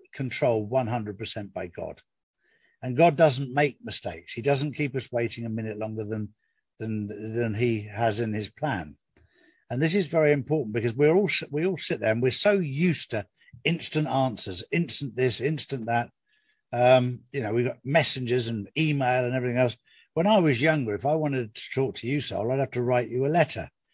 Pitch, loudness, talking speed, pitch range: 130 Hz, -26 LUFS, 195 wpm, 115-150 Hz